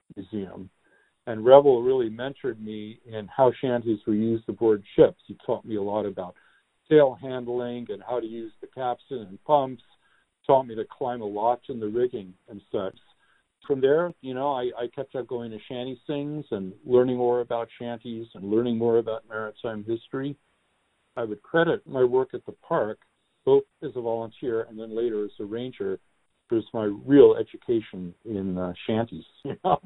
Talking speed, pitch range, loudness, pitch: 180 wpm, 110-135 Hz, -26 LUFS, 120 Hz